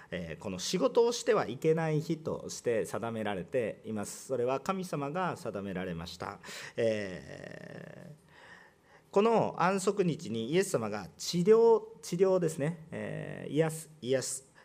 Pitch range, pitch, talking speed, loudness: 125-190 Hz, 160 Hz, 265 characters per minute, -32 LUFS